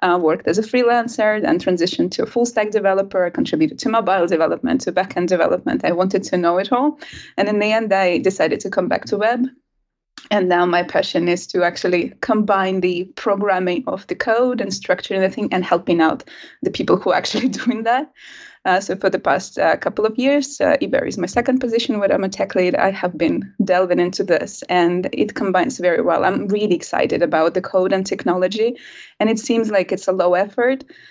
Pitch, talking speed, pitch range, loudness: 195 Hz, 215 wpm, 180-240 Hz, -18 LUFS